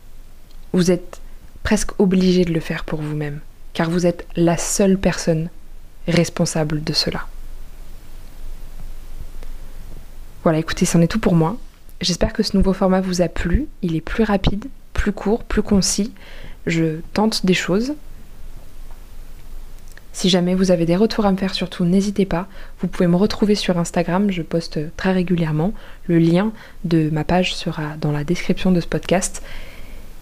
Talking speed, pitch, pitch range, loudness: 155 wpm, 180 Hz, 170-195 Hz, -19 LUFS